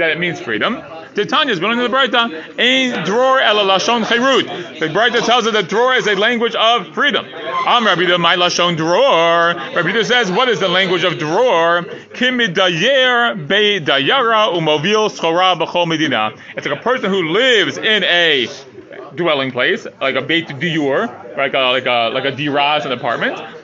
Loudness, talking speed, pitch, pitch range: -14 LUFS, 160 wpm, 180 Hz, 160-230 Hz